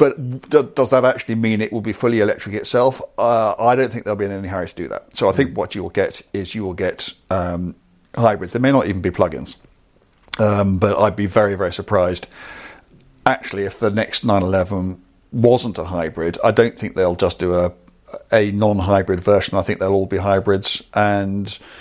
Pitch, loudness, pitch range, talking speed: 100 Hz, -19 LUFS, 95-110 Hz, 205 wpm